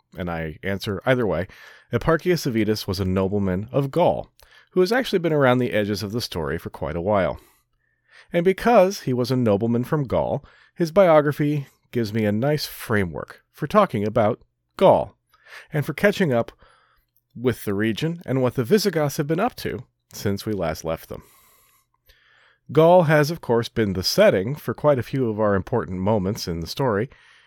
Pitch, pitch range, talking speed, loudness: 125 Hz, 105-155 Hz, 180 wpm, -22 LUFS